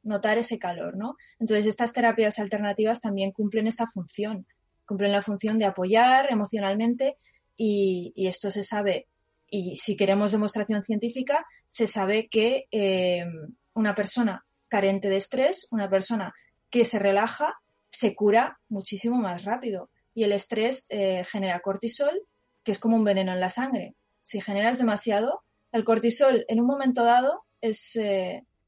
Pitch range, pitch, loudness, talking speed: 200-235 Hz, 215 Hz, -26 LUFS, 150 wpm